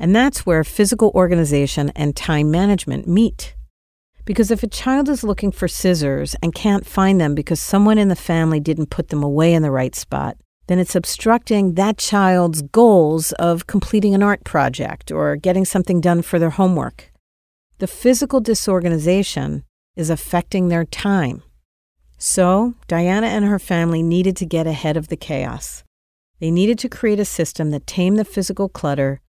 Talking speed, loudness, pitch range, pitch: 170 wpm, -17 LUFS, 150-200 Hz, 175 Hz